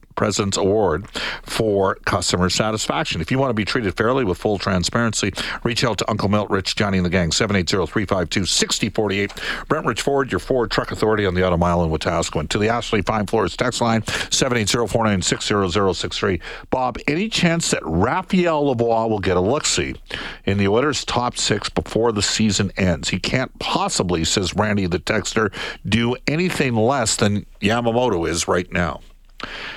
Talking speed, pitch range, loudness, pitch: 165 wpm, 95-120 Hz, -20 LUFS, 110 Hz